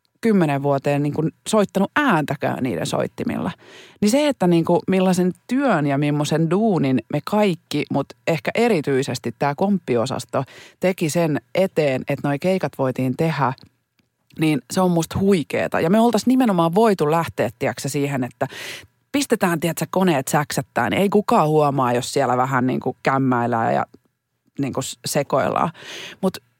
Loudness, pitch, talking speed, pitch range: -20 LUFS, 155 Hz, 150 wpm, 135-190 Hz